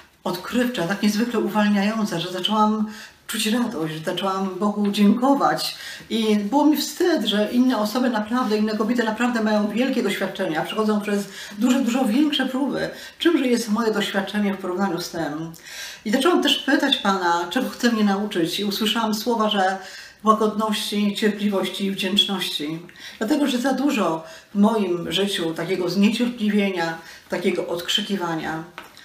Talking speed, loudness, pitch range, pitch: 140 wpm, -22 LUFS, 190-240 Hz, 210 Hz